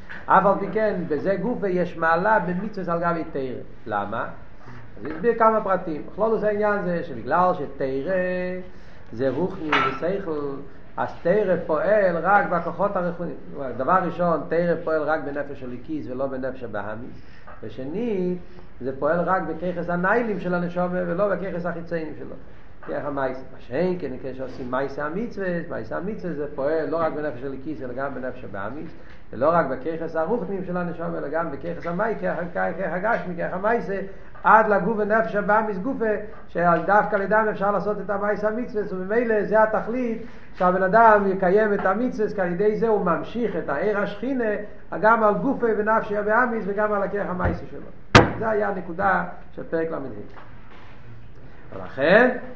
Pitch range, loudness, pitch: 145-210 Hz, -23 LUFS, 180 Hz